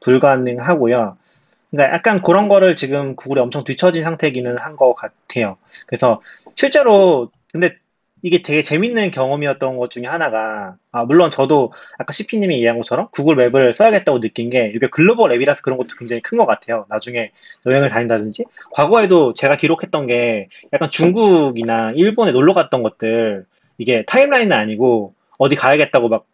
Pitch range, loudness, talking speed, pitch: 120-175 Hz, -15 LUFS, 380 characters per minute, 135 Hz